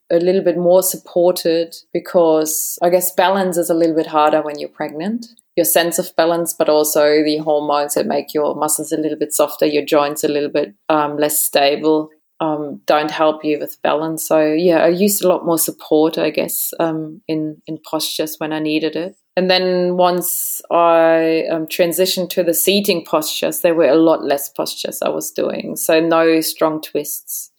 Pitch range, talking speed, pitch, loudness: 155-175 Hz, 190 wpm, 160 Hz, -16 LUFS